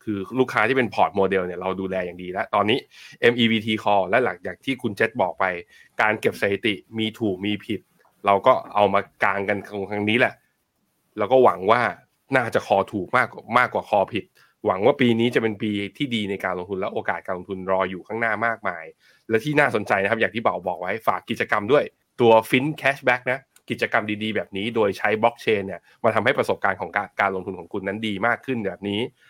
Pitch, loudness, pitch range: 105 Hz, -22 LUFS, 95-115 Hz